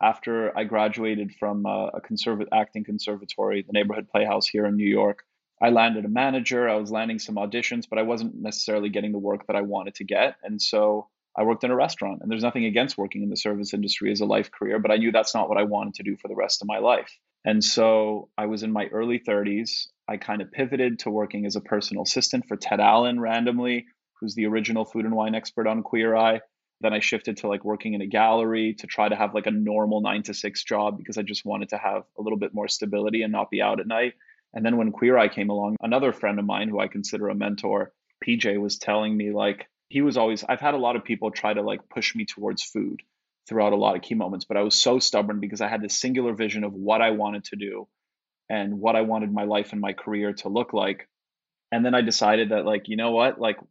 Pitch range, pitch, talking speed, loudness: 105-115 Hz, 110 Hz, 250 wpm, -24 LUFS